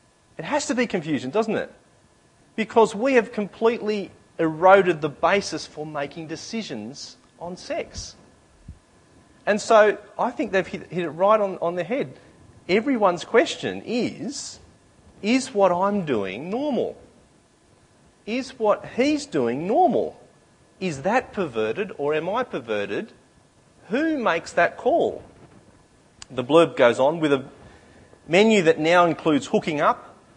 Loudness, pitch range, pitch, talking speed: -22 LUFS, 160-220 Hz, 195 Hz, 130 wpm